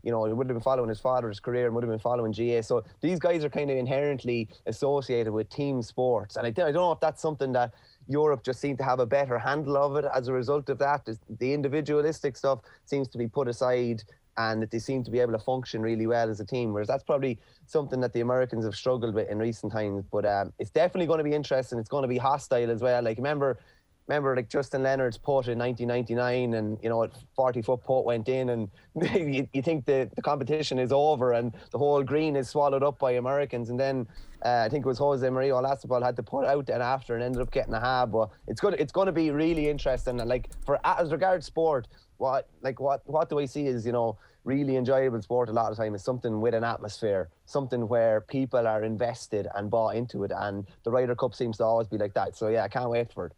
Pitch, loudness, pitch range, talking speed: 125 Hz, -28 LUFS, 115-140 Hz, 250 wpm